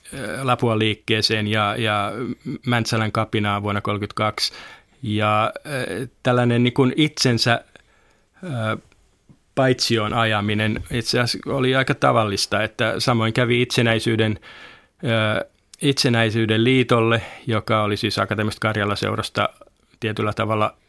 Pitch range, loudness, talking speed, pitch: 105-120 Hz, -21 LUFS, 90 wpm, 110 Hz